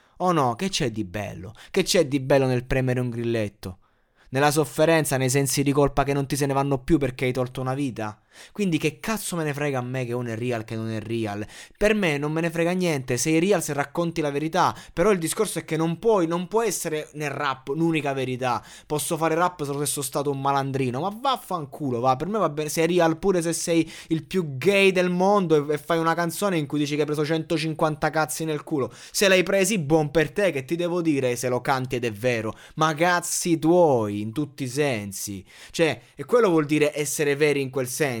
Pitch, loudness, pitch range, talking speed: 150 Hz, -24 LUFS, 130-170 Hz, 230 wpm